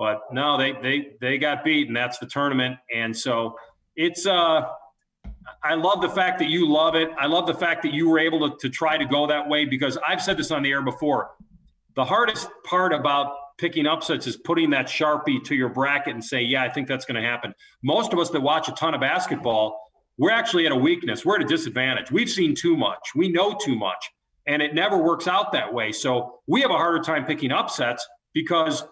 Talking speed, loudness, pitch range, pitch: 230 wpm, -23 LUFS, 135-170 Hz, 150 Hz